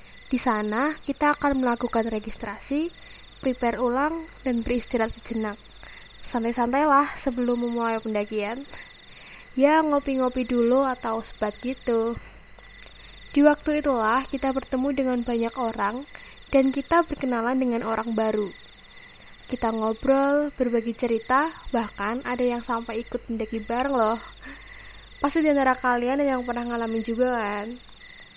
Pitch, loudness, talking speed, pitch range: 245 Hz, -25 LUFS, 120 wpm, 230-270 Hz